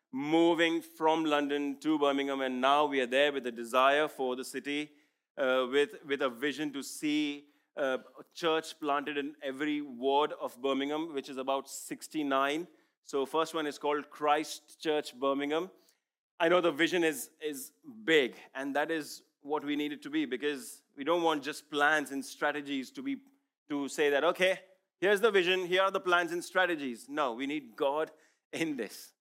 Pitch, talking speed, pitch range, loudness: 150 Hz, 185 wpm, 140-170 Hz, -31 LUFS